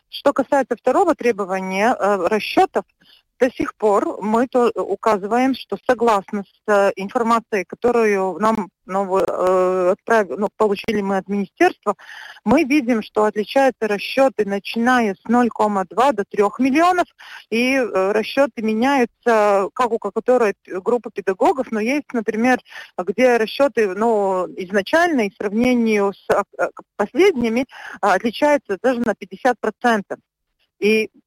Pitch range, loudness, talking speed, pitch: 200-250 Hz, -19 LUFS, 115 wpm, 220 Hz